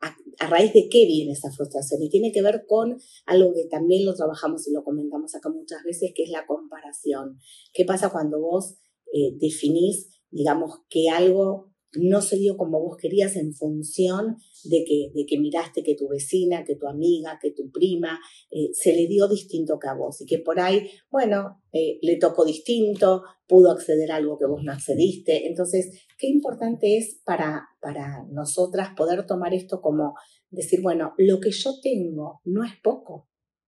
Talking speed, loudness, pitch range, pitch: 185 wpm, -23 LUFS, 155-195 Hz, 175 Hz